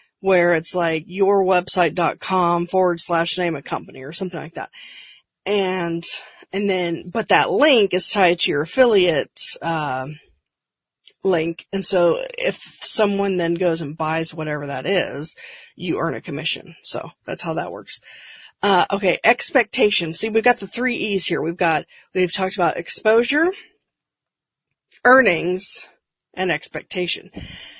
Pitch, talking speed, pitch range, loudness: 185 Hz, 140 wpm, 170-220 Hz, -20 LUFS